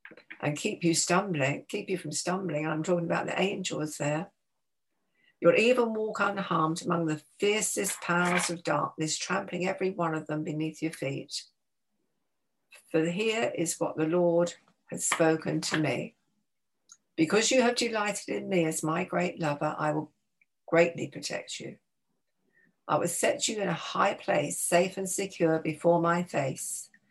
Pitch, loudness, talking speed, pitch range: 170 Hz, -29 LUFS, 155 wpm, 155-190 Hz